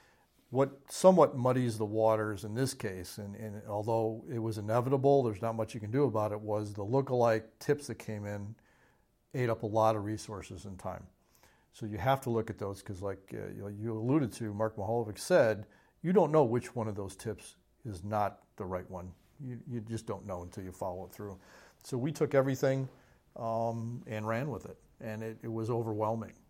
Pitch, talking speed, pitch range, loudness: 110 Hz, 205 wpm, 105-120 Hz, -33 LUFS